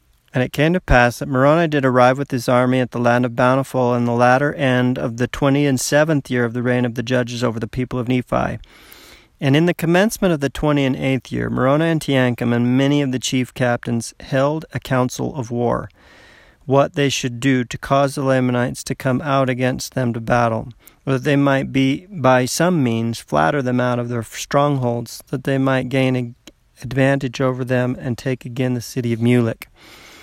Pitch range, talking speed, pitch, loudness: 125-140 Hz, 210 wpm, 130 Hz, -18 LUFS